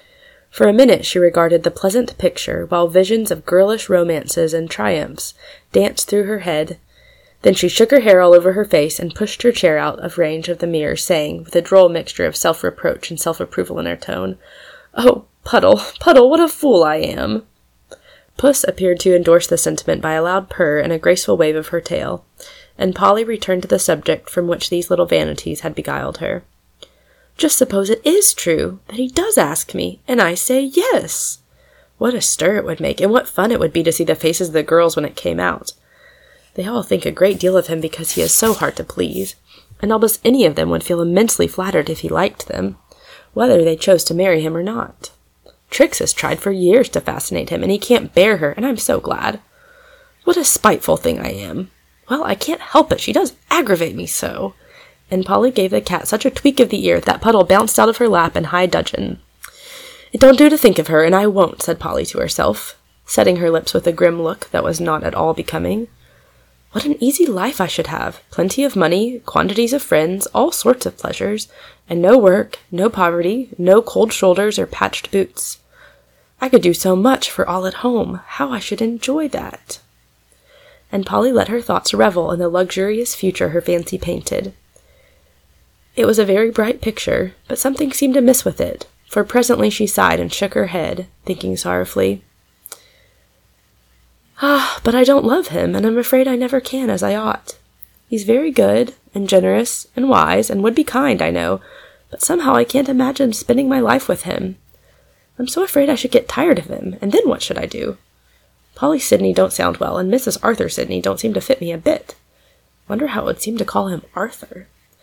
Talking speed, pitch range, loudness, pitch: 210 wpm, 170-260 Hz, -16 LUFS, 200 Hz